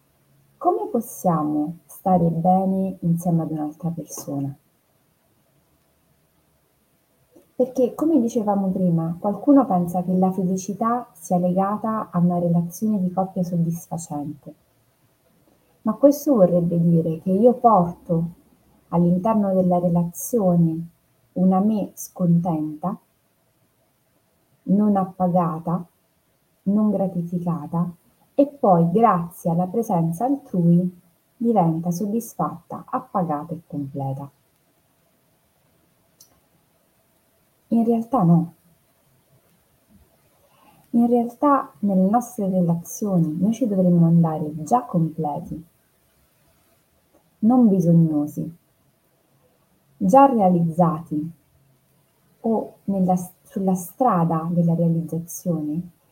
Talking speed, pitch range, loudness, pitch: 80 wpm, 165-205 Hz, -21 LUFS, 180 Hz